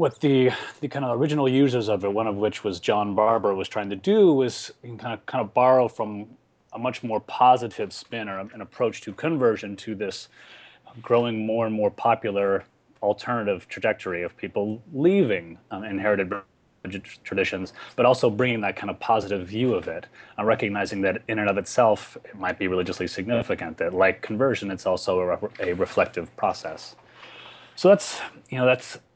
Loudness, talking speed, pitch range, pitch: -24 LUFS, 180 wpm, 100-125 Hz, 110 Hz